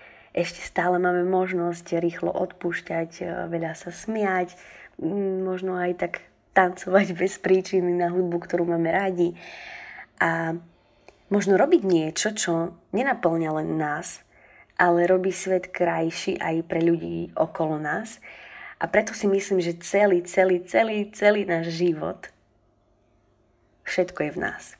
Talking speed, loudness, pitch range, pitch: 125 wpm, -24 LUFS, 165-190 Hz, 175 Hz